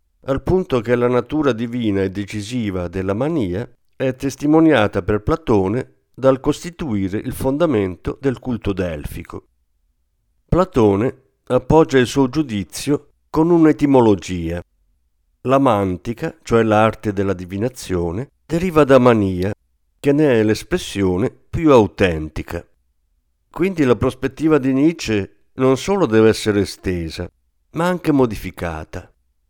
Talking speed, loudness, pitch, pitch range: 115 wpm, -18 LUFS, 110 Hz, 90-135 Hz